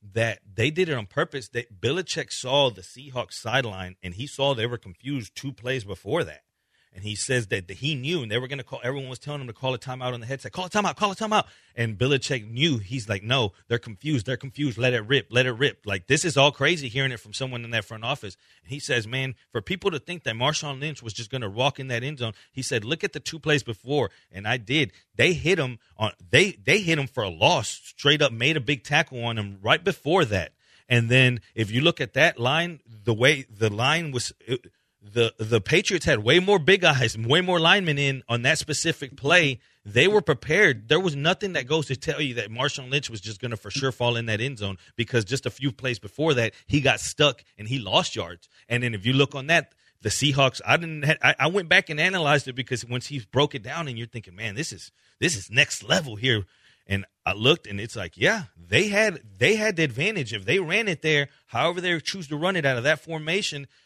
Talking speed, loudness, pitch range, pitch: 250 wpm, -24 LUFS, 115-150 Hz, 130 Hz